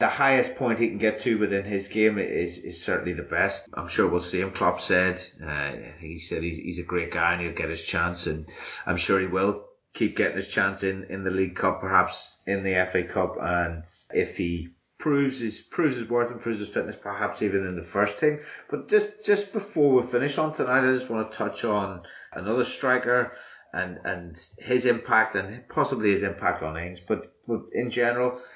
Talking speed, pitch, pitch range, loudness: 215 wpm, 105 Hz, 90-120 Hz, -26 LUFS